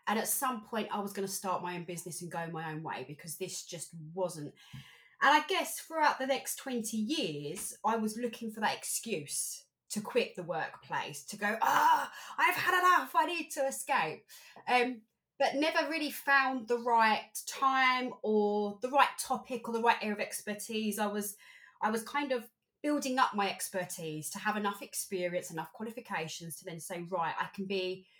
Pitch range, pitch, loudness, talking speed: 185-265 Hz, 220 Hz, -33 LUFS, 190 wpm